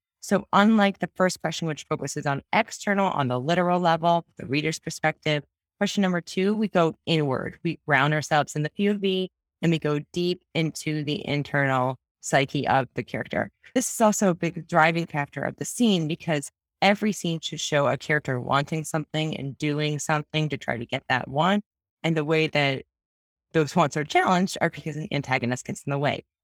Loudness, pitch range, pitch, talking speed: -25 LUFS, 140-175 Hz, 155 Hz, 190 wpm